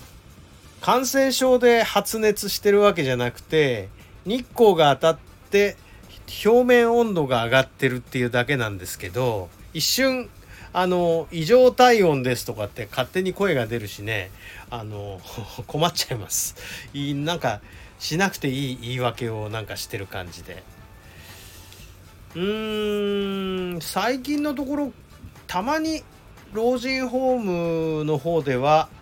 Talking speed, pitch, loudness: 250 characters per minute, 150 Hz, -22 LUFS